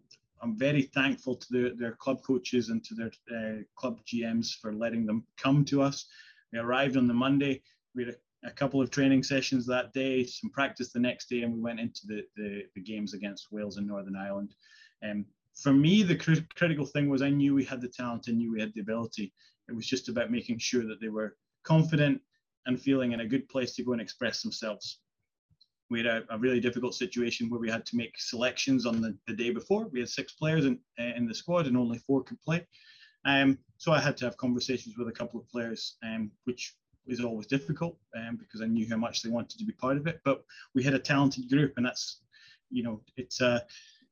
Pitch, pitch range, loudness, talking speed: 125 Hz, 115-140 Hz, -31 LUFS, 230 wpm